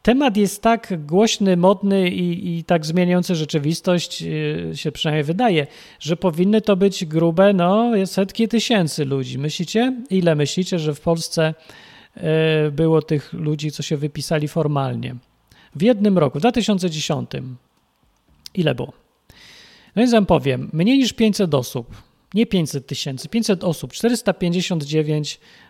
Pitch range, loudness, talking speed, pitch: 155-200 Hz, -19 LUFS, 130 wpm, 175 Hz